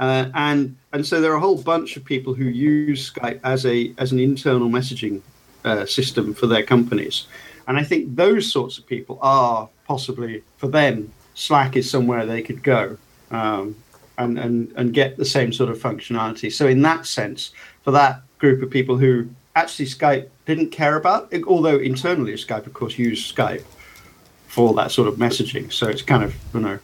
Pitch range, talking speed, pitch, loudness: 120-145 Hz, 190 wpm, 130 Hz, -20 LUFS